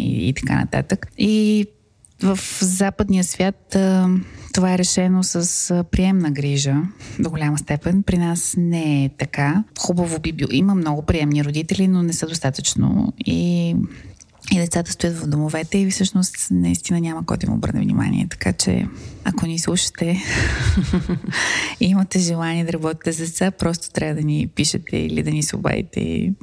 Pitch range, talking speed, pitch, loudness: 150-190 Hz, 155 wpm, 170 Hz, -20 LUFS